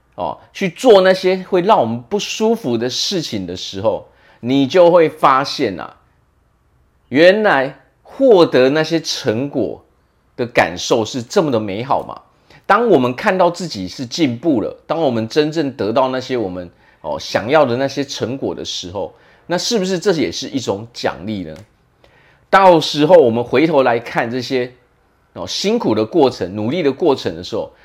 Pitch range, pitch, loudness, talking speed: 125-185 Hz, 150 Hz, -16 LUFS, 240 characters per minute